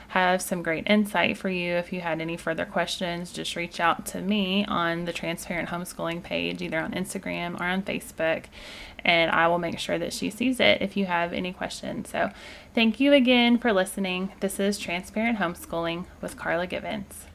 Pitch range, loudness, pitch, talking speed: 170-200 Hz, -26 LUFS, 180 Hz, 190 wpm